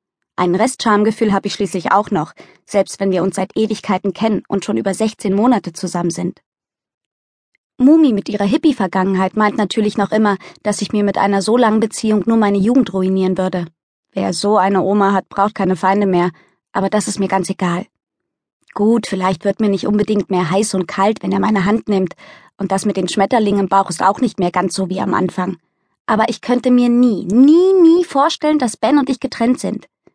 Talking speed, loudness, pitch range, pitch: 205 wpm, -16 LUFS, 190-220 Hz, 200 Hz